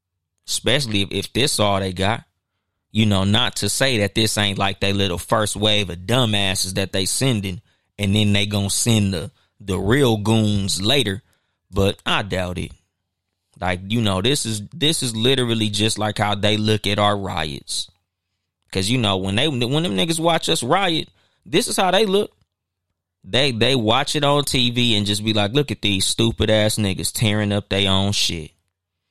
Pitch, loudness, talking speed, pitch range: 105 Hz, -19 LUFS, 190 wpm, 95-115 Hz